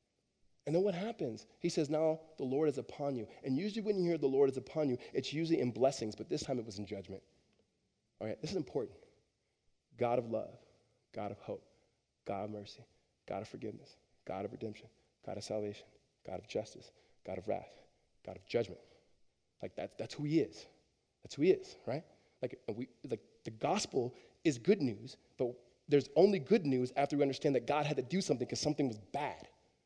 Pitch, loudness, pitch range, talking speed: 135 Hz, -37 LUFS, 110-155 Hz, 205 wpm